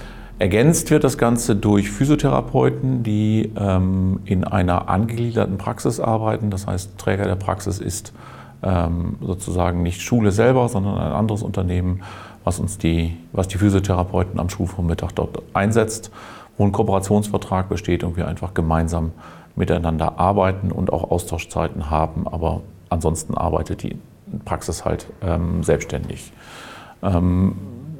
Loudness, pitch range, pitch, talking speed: -21 LUFS, 85-105 Hz, 95 Hz, 130 wpm